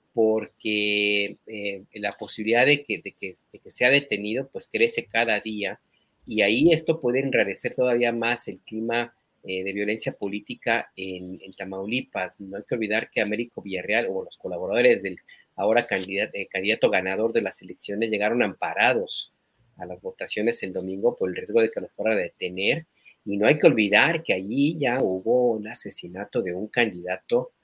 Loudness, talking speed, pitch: -24 LUFS, 180 wpm, 115 Hz